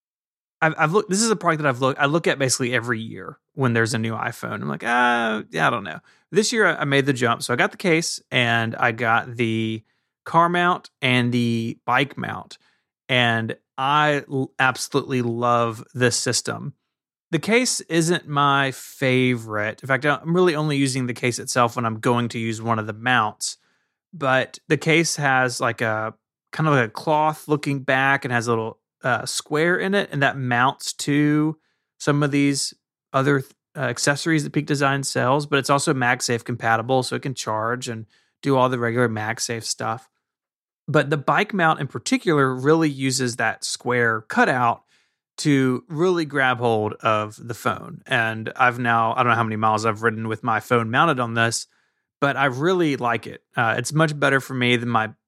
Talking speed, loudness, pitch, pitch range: 195 wpm, -21 LUFS, 130 Hz, 120-150 Hz